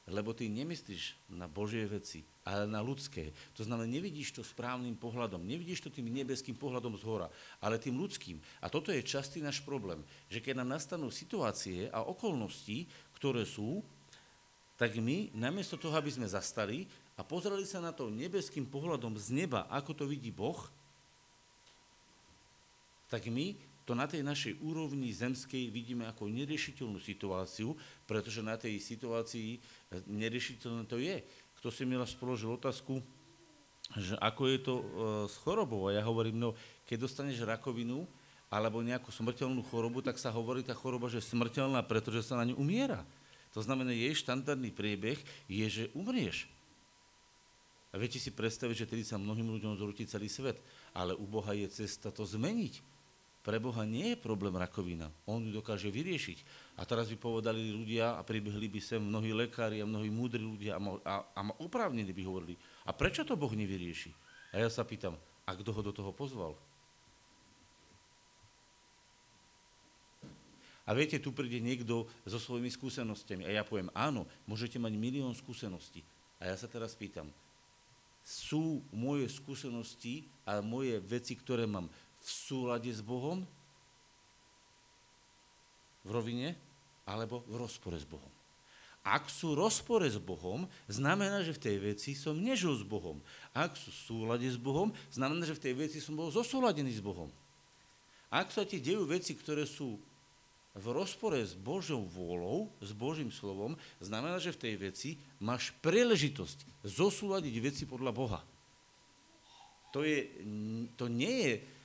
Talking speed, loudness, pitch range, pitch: 155 wpm, -38 LUFS, 105-140 Hz, 120 Hz